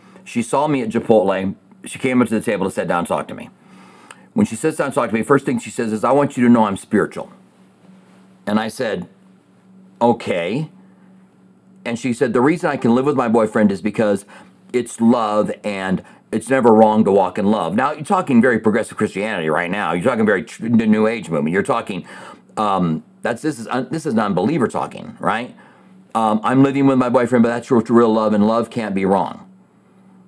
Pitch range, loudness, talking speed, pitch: 110-145 Hz, -18 LUFS, 210 wpm, 120 Hz